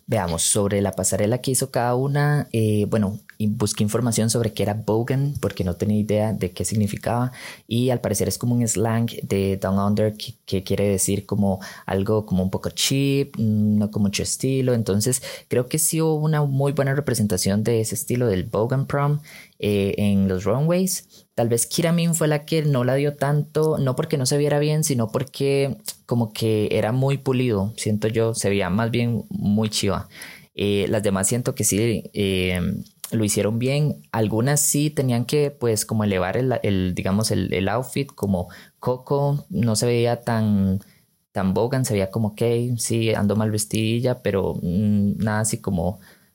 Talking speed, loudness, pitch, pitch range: 185 wpm, -22 LUFS, 115 Hz, 100-130 Hz